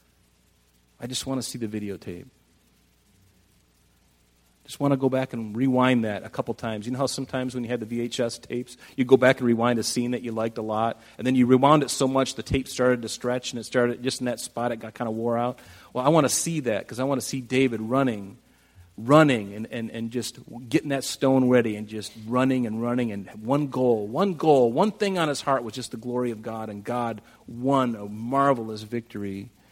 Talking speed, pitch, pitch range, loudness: 230 wpm, 120 Hz, 110-130 Hz, -25 LUFS